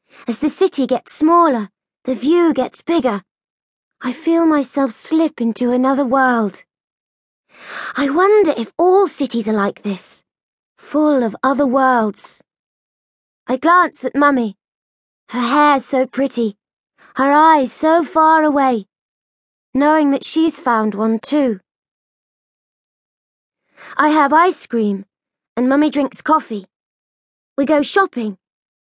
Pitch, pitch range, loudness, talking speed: 270 Hz, 235-305 Hz, -16 LUFS, 120 wpm